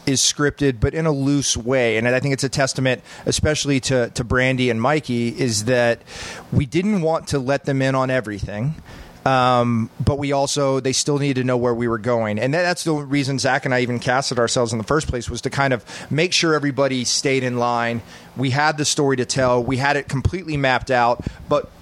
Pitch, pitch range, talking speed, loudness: 130 Hz, 120-140 Hz, 225 wpm, -20 LUFS